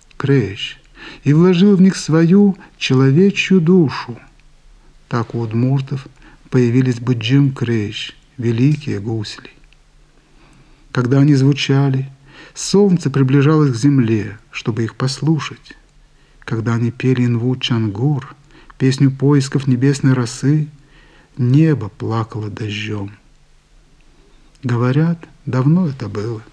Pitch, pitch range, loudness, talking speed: 135 Hz, 120-150 Hz, -16 LUFS, 95 wpm